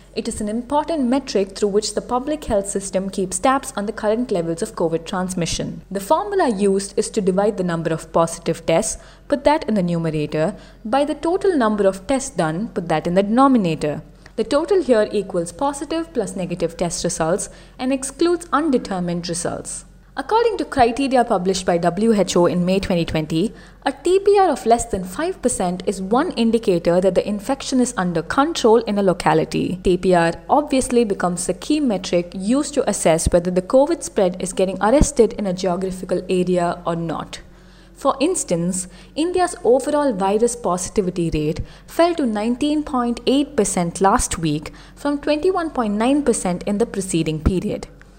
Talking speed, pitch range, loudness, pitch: 160 wpm, 180-265 Hz, -20 LUFS, 210 Hz